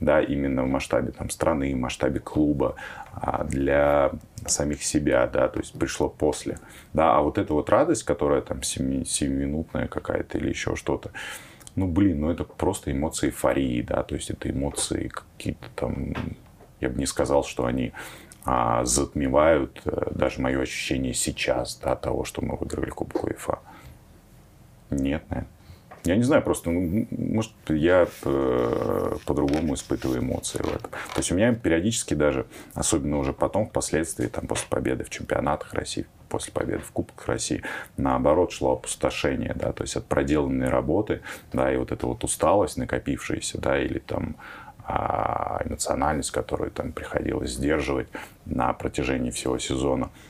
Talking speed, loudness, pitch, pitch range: 155 wpm, -26 LUFS, 70 Hz, 65-75 Hz